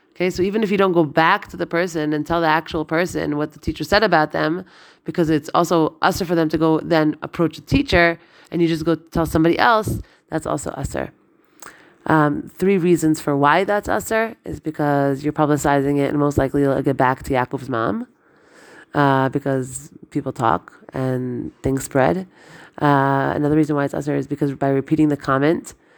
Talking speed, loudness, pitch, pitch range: 195 wpm, -19 LUFS, 155 Hz, 140-170 Hz